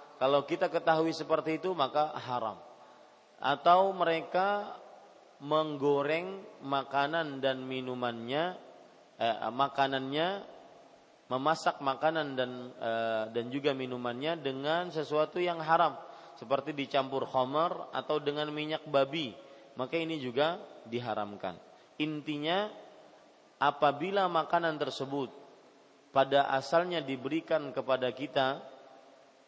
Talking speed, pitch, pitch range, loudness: 95 wpm, 145 Hz, 135-165 Hz, -32 LUFS